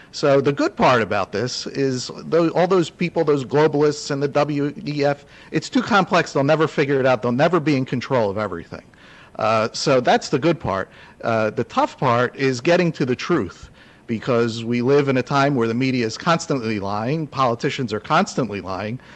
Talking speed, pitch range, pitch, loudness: 190 wpm, 120-155 Hz, 140 Hz, -20 LUFS